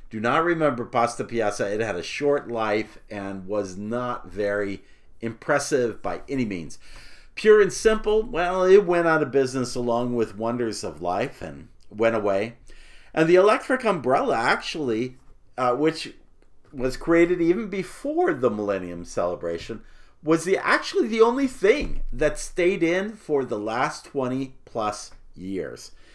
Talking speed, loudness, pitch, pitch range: 145 wpm, -24 LUFS, 130 Hz, 110-170 Hz